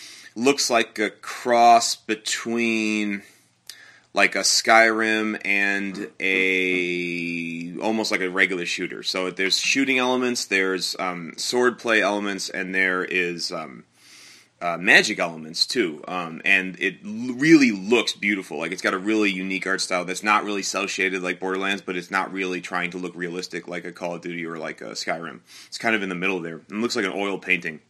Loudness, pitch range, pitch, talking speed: -22 LUFS, 90-110 Hz, 95 Hz, 180 wpm